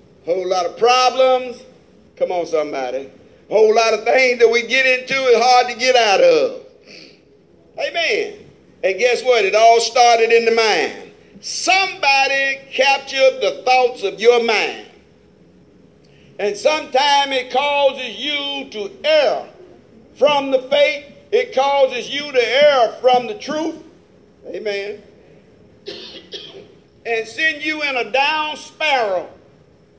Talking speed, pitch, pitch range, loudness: 130 wpm, 265 Hz, 230-295 Hz, -16 LUFS